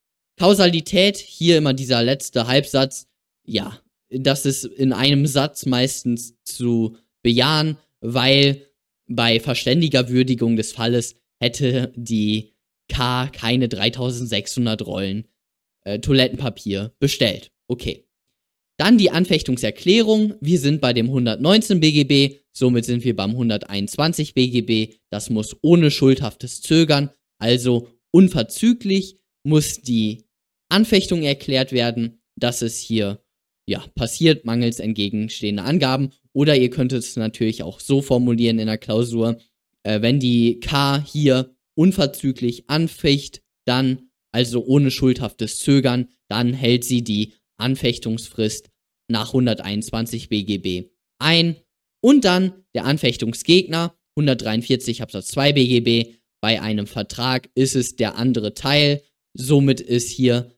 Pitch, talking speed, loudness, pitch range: 125 Hz, 115 wpm, -19 LUFS, 115-140 Hz